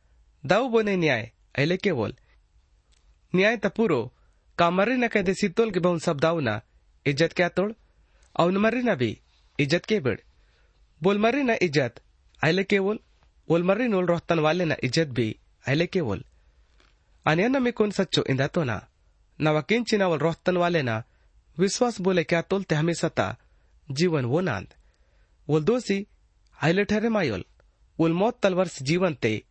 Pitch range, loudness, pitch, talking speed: 120-195 Hz, -25 LUFS, 170 Hz, 140 wpm